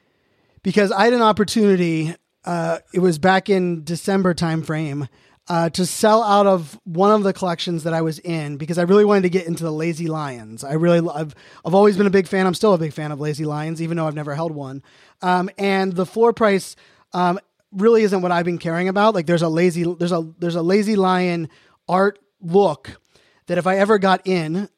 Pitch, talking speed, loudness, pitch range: 175 Hz, 220 wpm, -19 LUFS, 165-195 Hz